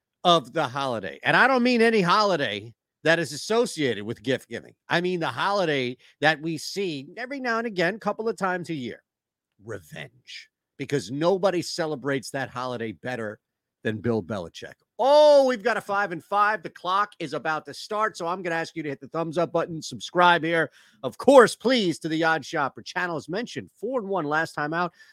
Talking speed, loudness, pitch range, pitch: 205 wpm, -24 LUFS, 135-190 Hz, 165 Hz